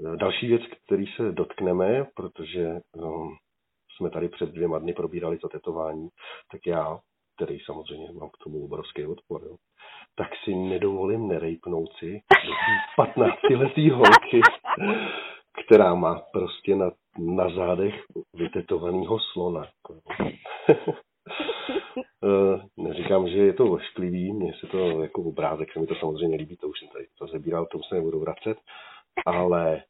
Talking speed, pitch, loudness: 135 wpm, 115 Hz, -24 LUFS